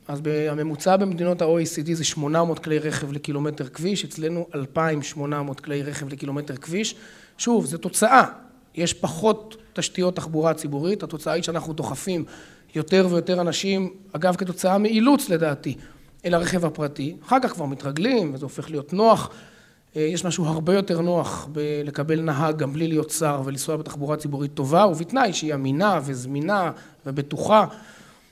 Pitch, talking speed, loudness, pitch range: 160 Hz, 140 wpm, -23 LUFS, 150-180 Hz